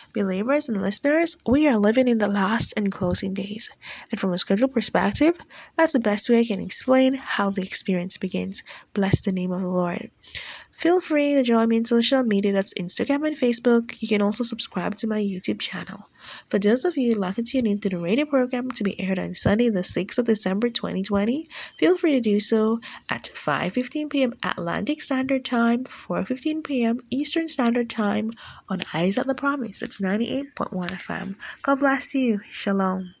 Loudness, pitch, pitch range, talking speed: -22 LUFS, 230 Hz, 200-265 Hz, 200 wpm